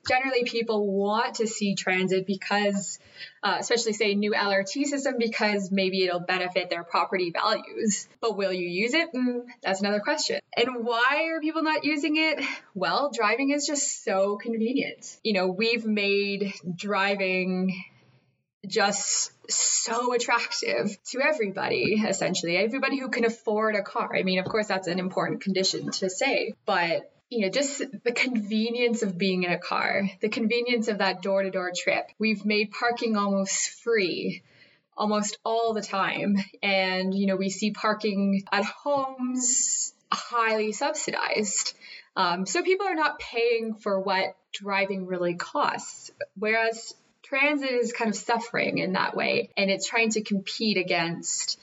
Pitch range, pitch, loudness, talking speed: 195-240 Hz, 215 Hz, -26 LUFS, 155 wpm